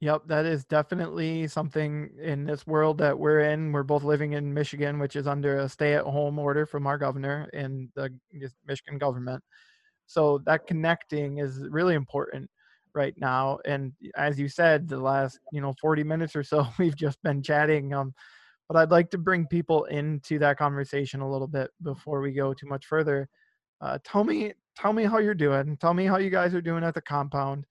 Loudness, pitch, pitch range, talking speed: -27 LUFS, 145 Hz, 140-160 Hz, 200 wpm